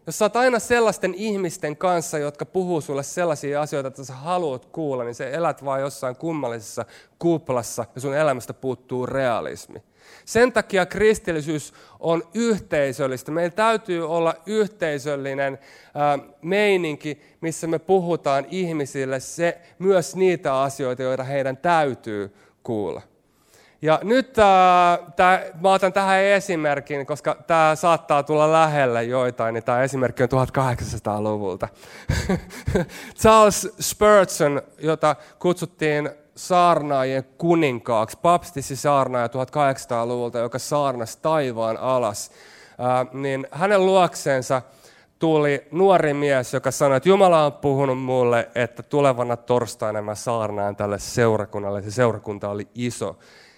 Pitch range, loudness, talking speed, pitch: 130-170 Hz, -21 LUFS, 120 wpm, 145 Hz